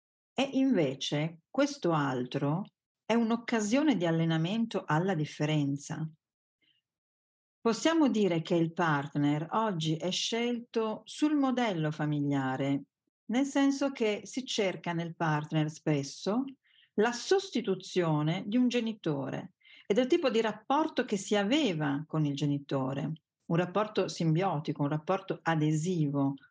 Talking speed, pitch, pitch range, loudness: 115 wpm, 175 Hz, 150-230 Hz, -31 LUFS